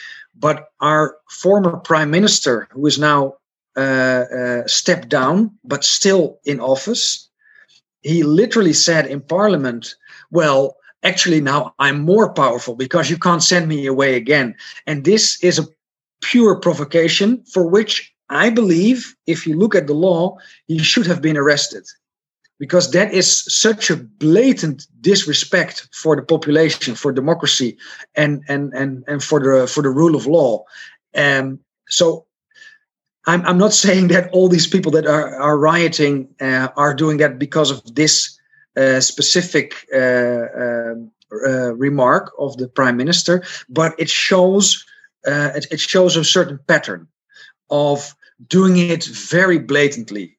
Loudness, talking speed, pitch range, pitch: -15 LUFS, 145 wpm, 140-180 Hz, 155 Hz